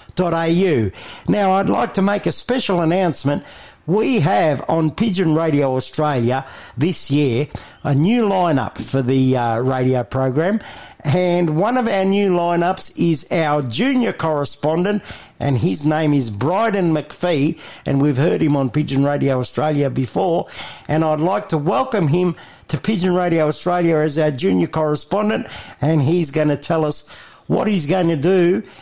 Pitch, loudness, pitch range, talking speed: 160 Hz, -18 LUFS, 145-180 Hz, 155 wpm